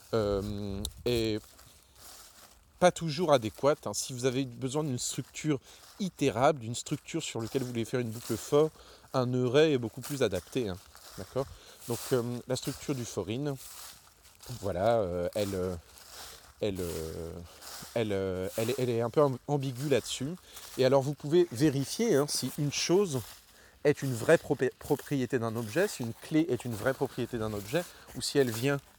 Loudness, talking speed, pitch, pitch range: -31 LUFS, 165 wpm, 125 Hz, 105-145 Hz